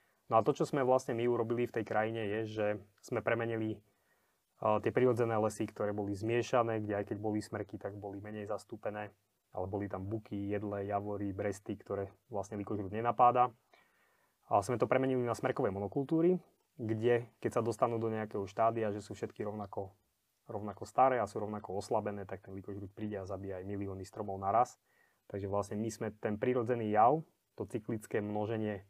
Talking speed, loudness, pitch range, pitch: 180 wpm, -35 LUFS, 100-115 Hz, 105 Hz